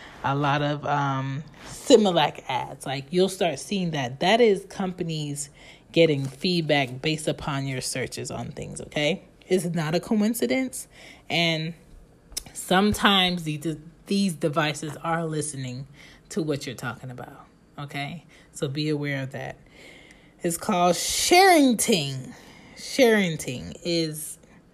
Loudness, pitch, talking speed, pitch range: -24 LUFS, 160 Hz, 125 wpm, 145-180 Hz